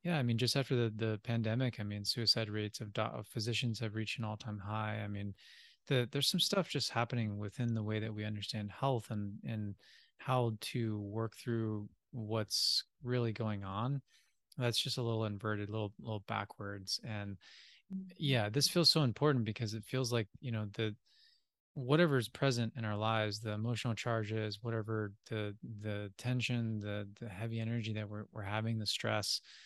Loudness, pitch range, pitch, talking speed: -36 LUFS, 105-120 Hz, 110 Hz, 185 wpm